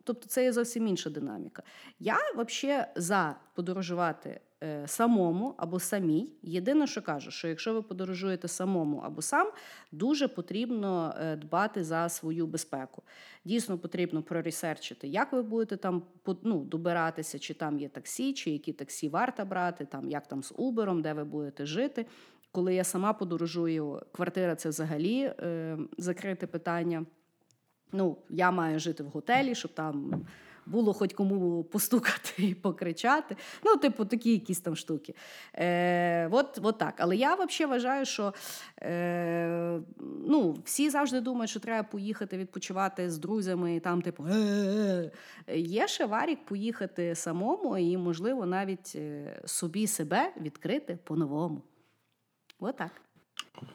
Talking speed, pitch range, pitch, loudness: 135 wpm, 165-225 Hz, 180 Hz, -32 LUFS